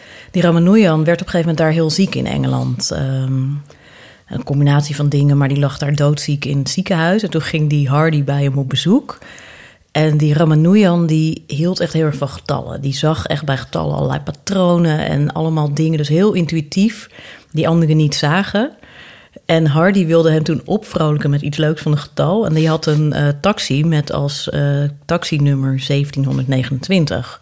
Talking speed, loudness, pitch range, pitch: 185 wpm, -15 LUFS, 145-170 Hz, 155 Hz